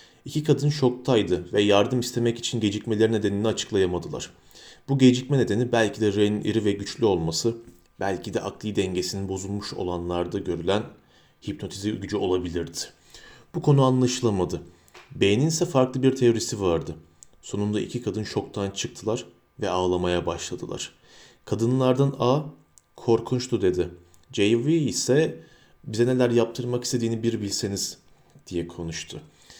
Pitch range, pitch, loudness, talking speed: 100-125 Hz, 110 Hz, -25 LUFS, 125 wpm